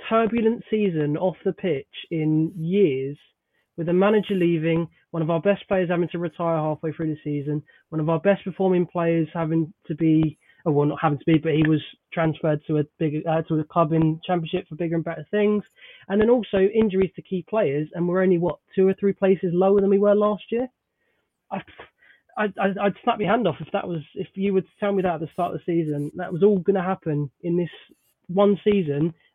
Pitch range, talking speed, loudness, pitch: 160-195 Hz, 220 wpm, -23 LUFS, 175 Hz